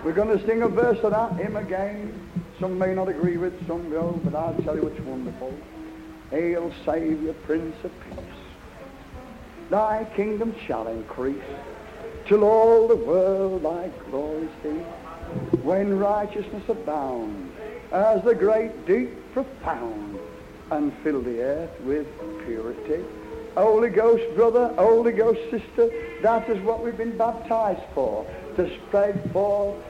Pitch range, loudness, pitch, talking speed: 160-225 Hz, -24 LUFS, 195 Hz, 135 wpm